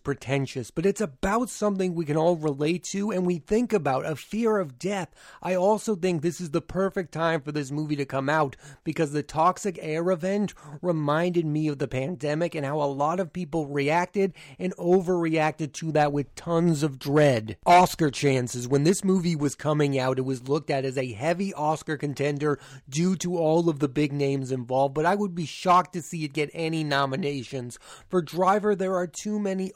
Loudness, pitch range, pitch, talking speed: -26 LUFS, 145-180 Hz, 160 Hz, 200 wpm